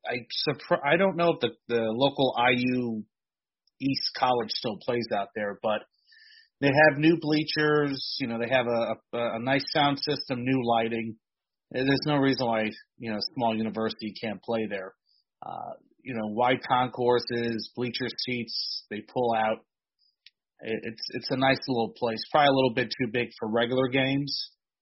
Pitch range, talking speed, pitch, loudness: 115-140 Hz, 165 wpm, 125 Hz, -27 LUFS